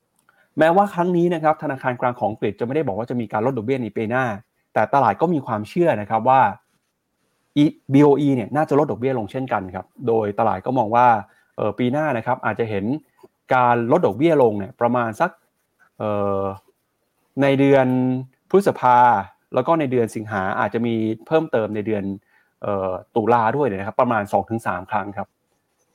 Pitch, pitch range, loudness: 125 Hz, 110-140 Hz, -20 LUFS